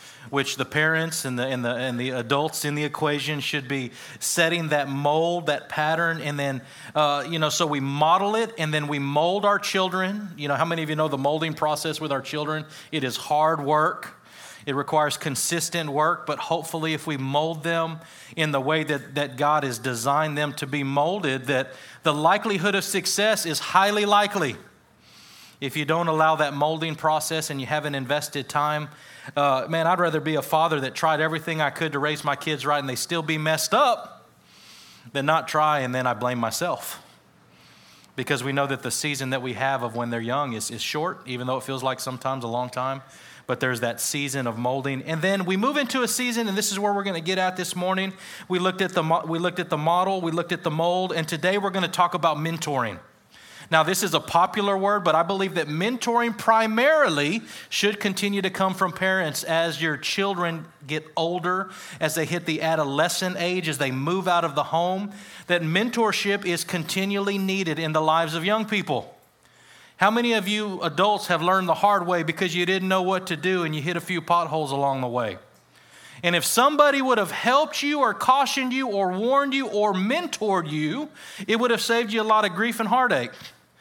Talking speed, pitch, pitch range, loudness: 215 wpm, 160 Hz, 145-190 Hz, -24 LUFS